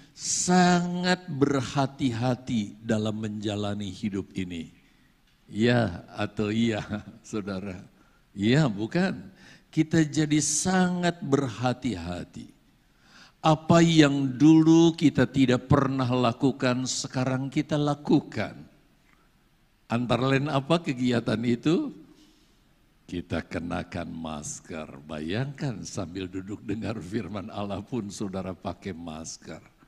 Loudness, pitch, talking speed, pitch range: -26 LUFS, 120 Hz, 90 wpm, 100-145 Hz